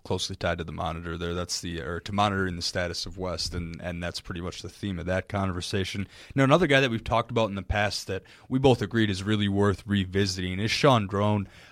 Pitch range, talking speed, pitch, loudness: 90-105 Hz, 235 wpm, 95 Hz, -27 LUFS